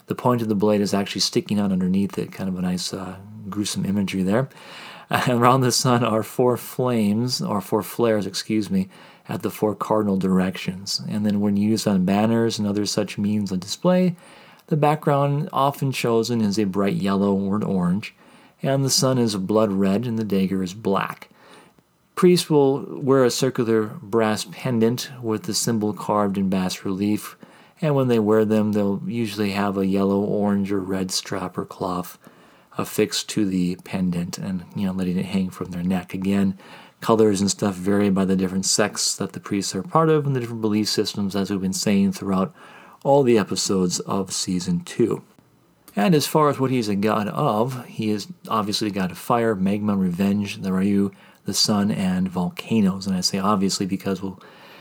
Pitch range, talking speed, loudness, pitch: 95-125 Hz, 190 wpm, -22 LUFS, 105 Hz